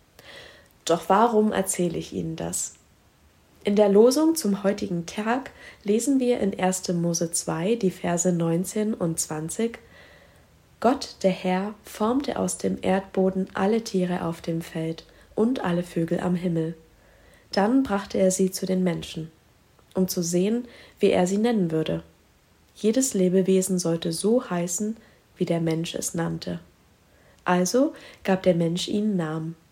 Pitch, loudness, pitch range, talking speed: 180 Hz, -25 LUFS, 160-205 Hz, 145 wpm